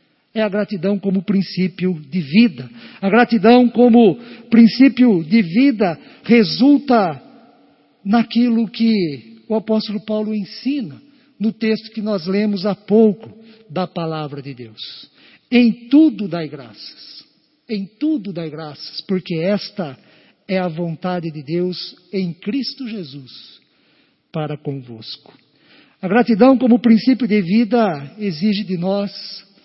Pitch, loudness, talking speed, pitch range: 210 Hz, -17 LUFS, 120 wpm, 180-235 Hz